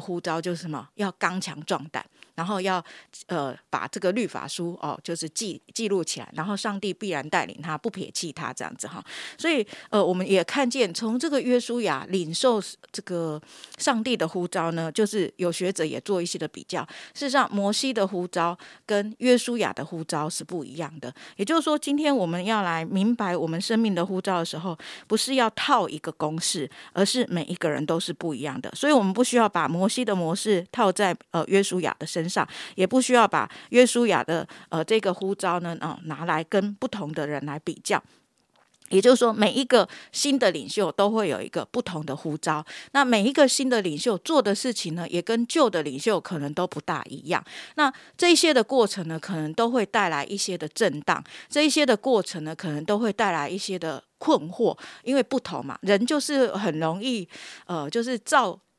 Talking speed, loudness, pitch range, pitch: 300 characters per minute, -25 LUFS, 165-235 Hz, 195 Hz